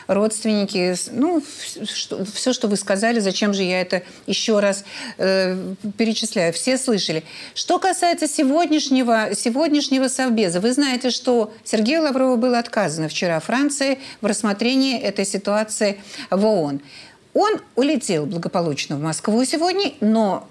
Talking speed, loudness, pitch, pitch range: 125 wpm, -20 LUFS, 220 Hz, 195-260 Hz